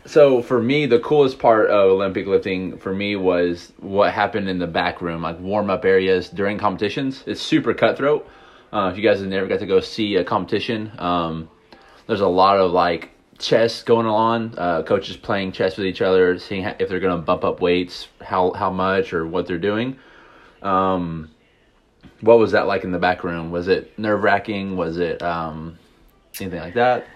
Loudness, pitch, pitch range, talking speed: -20 LUFS, 95 Hz, 90-110 Hz, 200 wpm